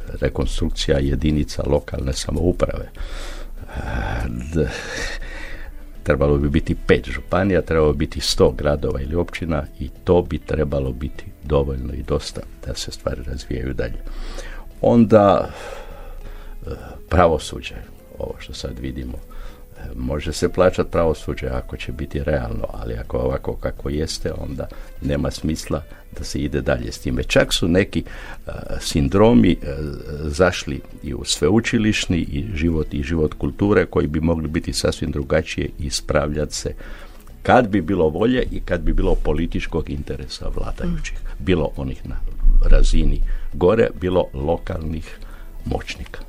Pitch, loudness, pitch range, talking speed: 75 Hz, -21 LUFS, 70-85 Hz, 130 wpm